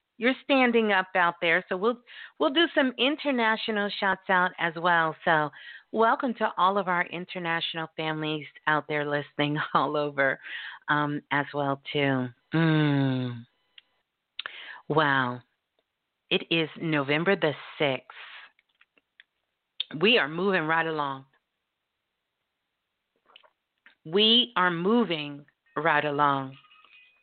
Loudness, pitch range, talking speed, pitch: -26 LUFS, 145-200 Hz, 110 wpm, 165 Hz